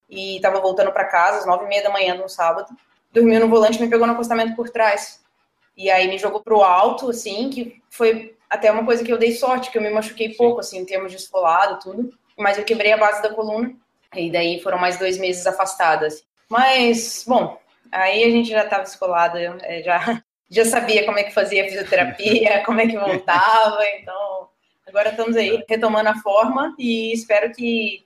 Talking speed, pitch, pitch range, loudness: 205 wpm, 210 Hz, 190-230 Hz, -18 LUFS